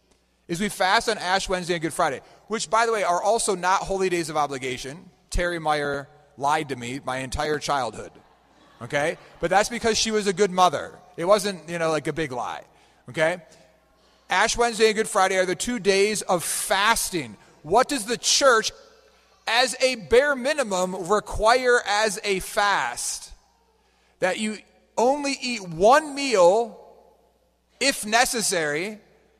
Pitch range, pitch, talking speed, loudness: 165-230 Hz, 195 Hz, 155 wpm, -23 LUFS